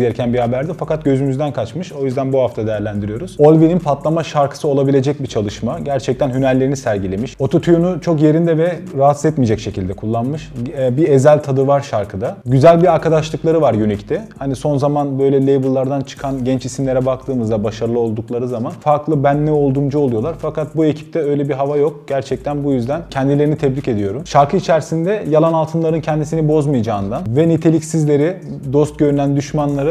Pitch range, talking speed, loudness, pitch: 130-155 Hz, 160 wpm, -16 LUFS, 140 Hz